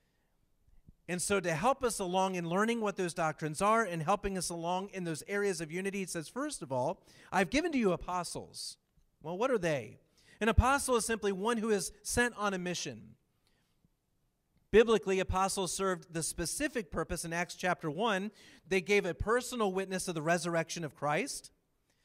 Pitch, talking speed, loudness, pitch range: 190 Hz, 180 wpm, -33 LUFS, 170-210 Hz